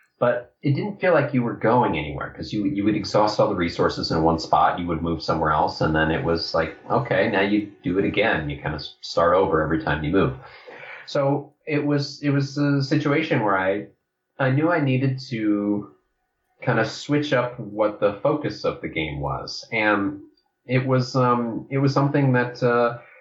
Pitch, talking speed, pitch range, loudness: 125 Hz, 205 wpm, 105-145 Hz, -22 LUFS